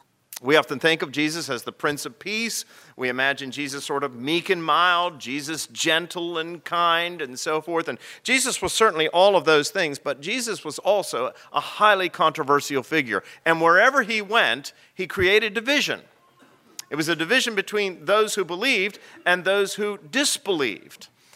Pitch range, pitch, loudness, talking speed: 150-205 Hz, 170 Hz, -22 LUFS, 170 wpm